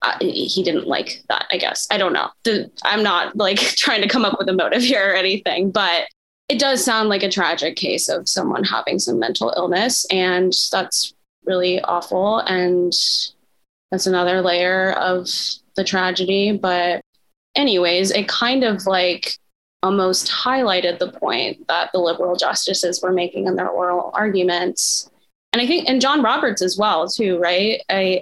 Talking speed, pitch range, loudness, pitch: 170 wpm, 180-210 Hz, -18 LUFS, 185 Hz